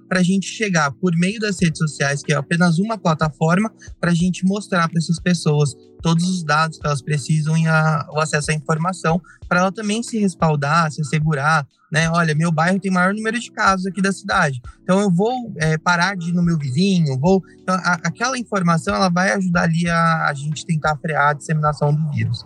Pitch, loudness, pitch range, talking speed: 170 Hz, -19 LUFS, 155-185 Hz, 210 wpm